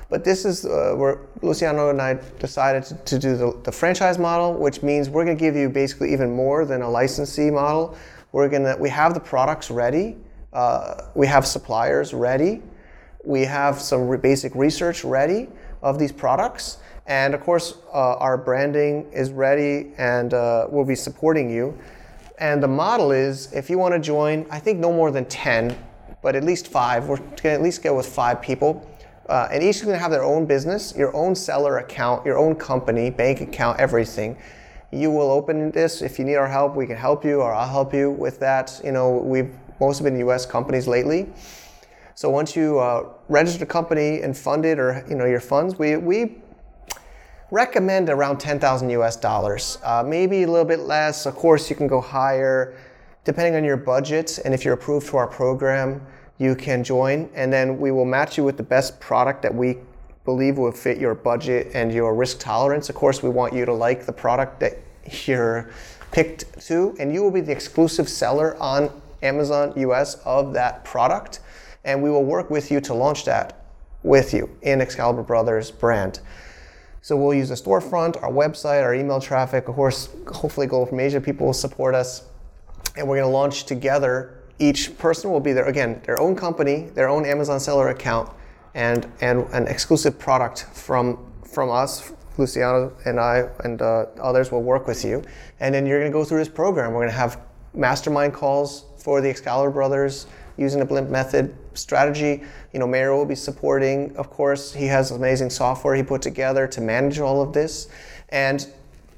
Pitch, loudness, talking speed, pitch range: 135 Hz, -21 LUFS, 195 wpm, 125-145 Hz